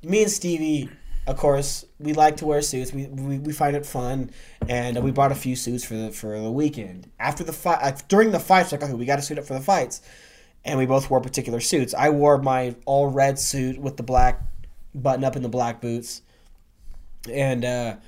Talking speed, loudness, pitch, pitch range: 220 wpm, -23 LUFS, 135 Hz, 125-145 Hz